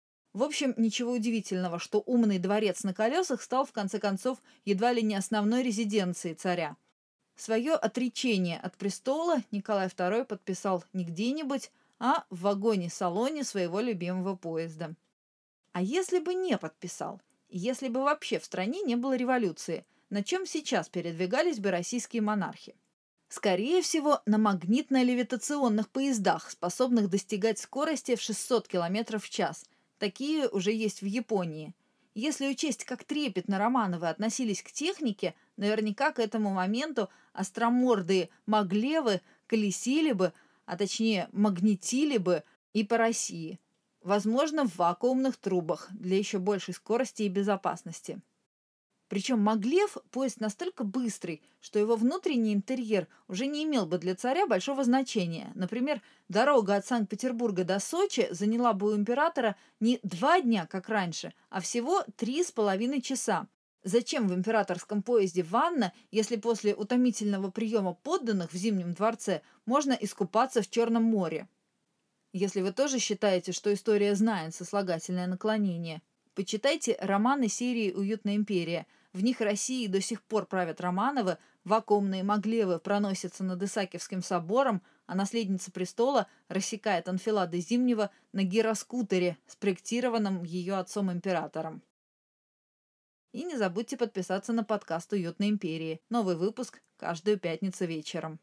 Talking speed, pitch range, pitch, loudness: 130 wpm, 190-245 Hz, 215 Hz, -30 LUFS